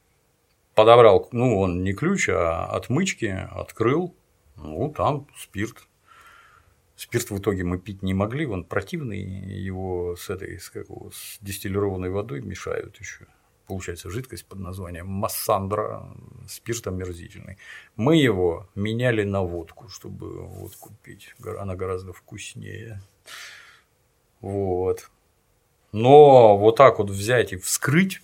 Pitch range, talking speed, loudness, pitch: 95-115 Hz, 115 wpm, -21 LUFS, 100 Hz